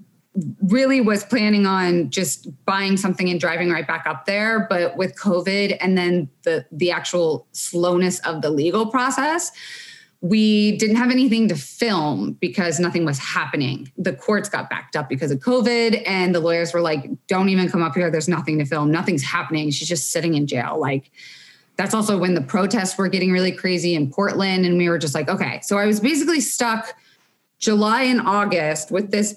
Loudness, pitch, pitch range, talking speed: -20 LUFS, 185 Hz, 165-210 Hz, 190 wpm